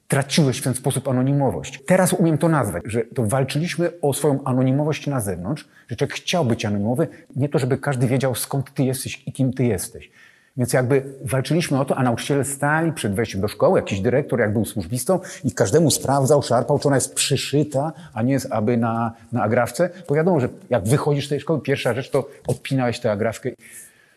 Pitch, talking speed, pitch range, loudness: 135 Hz, 200 wpm, 125-150 Hz, -21 LUFS